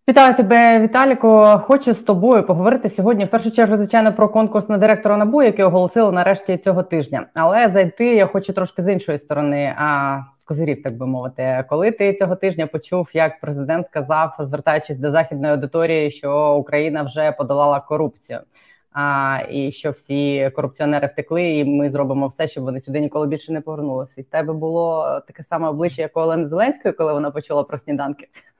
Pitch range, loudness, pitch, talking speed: 145-195 Hz, -17 LUFS, 160 Hz, 175 wpm